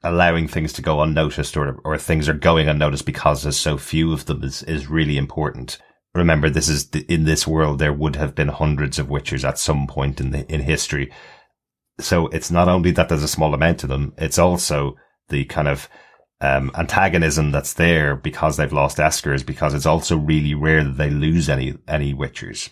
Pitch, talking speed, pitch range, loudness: 75 Hz, 205 wpm, 70-80 Hz, -19 LUFS